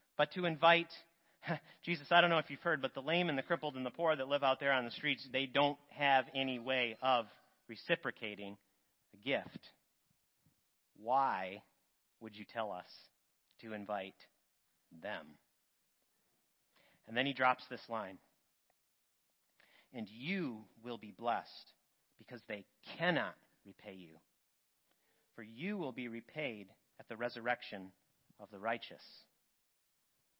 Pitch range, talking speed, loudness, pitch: 110-145 Hz, 140 wpm, -37 LUFS, 130 Hz